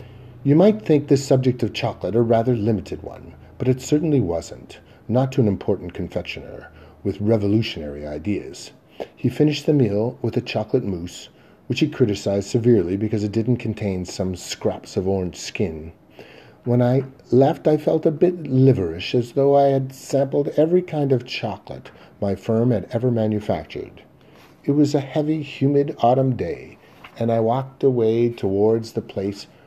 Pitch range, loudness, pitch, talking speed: 105-140 Hz, -21 LUFS, 120 Hz, 160 wpm